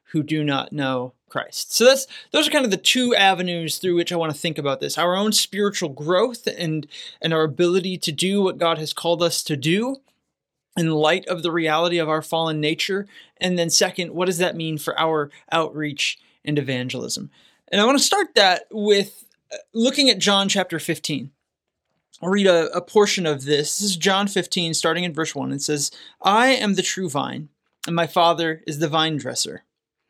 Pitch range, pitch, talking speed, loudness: 155-195 Hz, 170 Hz, 200 wpm, -20 LUFS